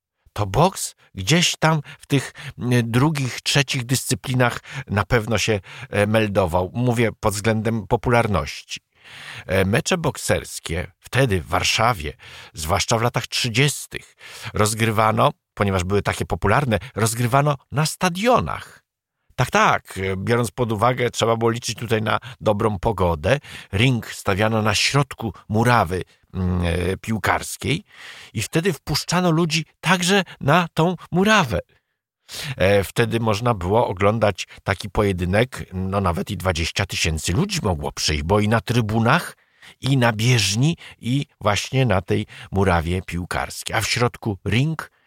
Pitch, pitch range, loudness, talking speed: 115 Hz, 100-130 Hz, -21 LUFS, 125 wpm